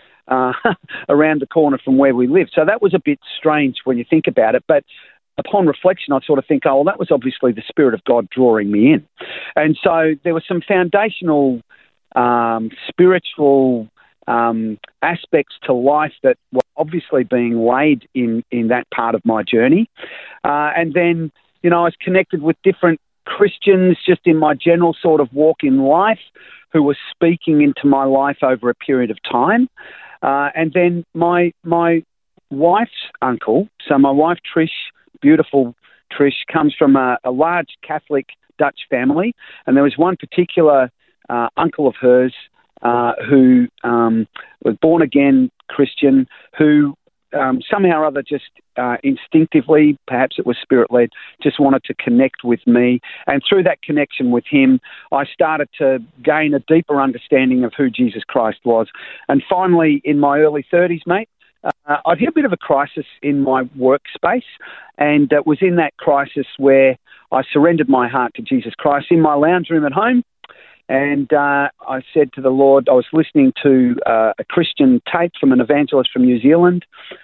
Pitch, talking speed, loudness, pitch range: 145 Hz, 175 wpm, -15 LUFS, 130-170 Hz